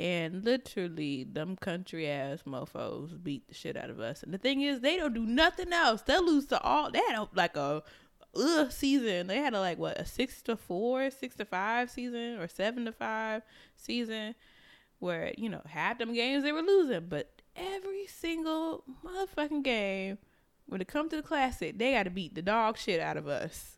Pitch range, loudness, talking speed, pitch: 185-285 Hz, -32 LUFS, 200 wpm, 235 Hz